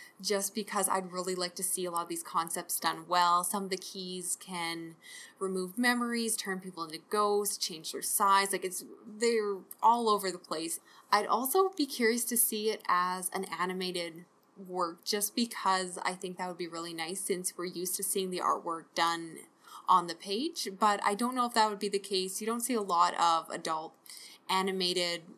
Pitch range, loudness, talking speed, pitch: 175-210 Hz, -31 LUFS, 200 wpm, 190 Hz